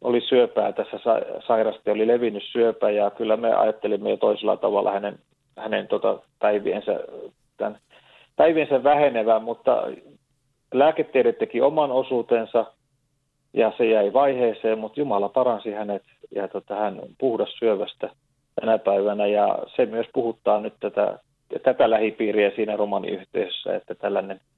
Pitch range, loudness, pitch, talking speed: 105-140 Hz, -23 LUFS, 115 Hz, 130 wpm